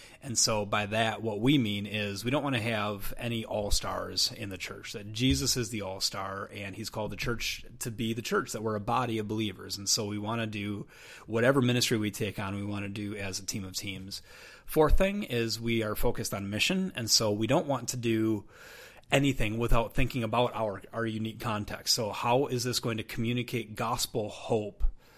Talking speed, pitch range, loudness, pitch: 220 wpm, 105-120 Hz, -30 LUFS, 110 Hz